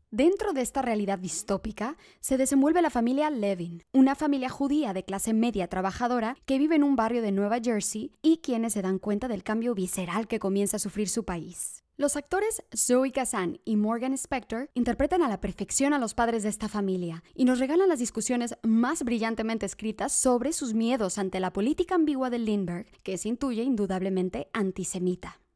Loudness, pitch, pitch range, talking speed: -27 LUFS, 230 Hz, 200-270 Hz, 185 wpm